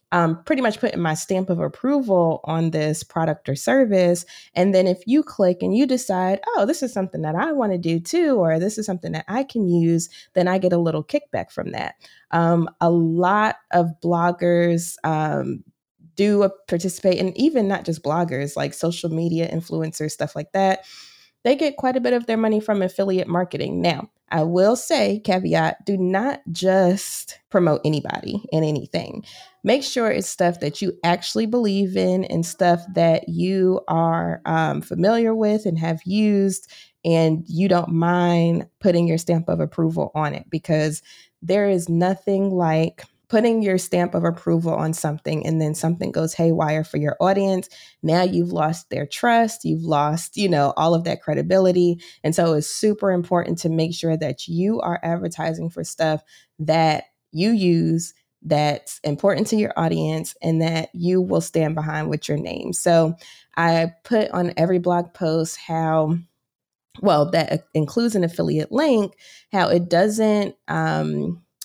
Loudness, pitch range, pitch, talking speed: -21 LUFS, 160-195 Hz, 175 Hz, 170 wpm